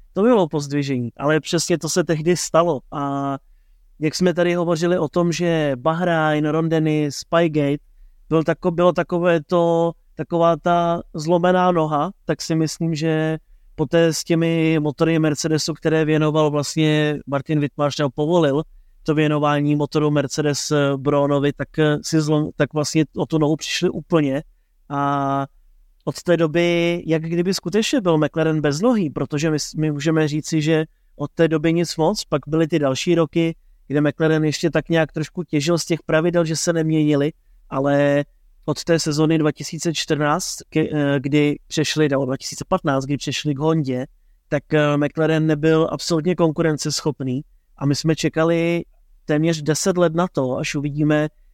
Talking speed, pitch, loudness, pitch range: 150 wpm, 155 Hz, -20 LUFS, 145-165 Hz